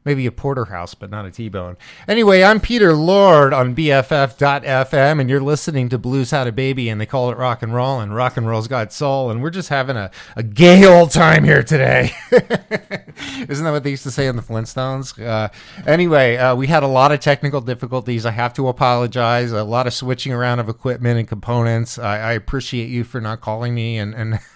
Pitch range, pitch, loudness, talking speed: 115-140 Hz, 130 Hz, -16 LUFS, 215 wpm